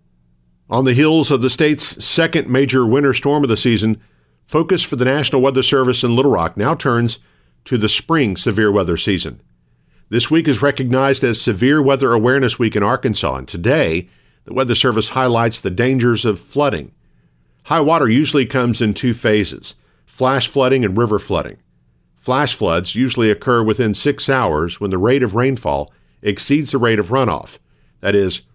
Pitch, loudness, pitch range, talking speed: 120 Hz, -16 LUFS, 100-135 Hz, 170 wpm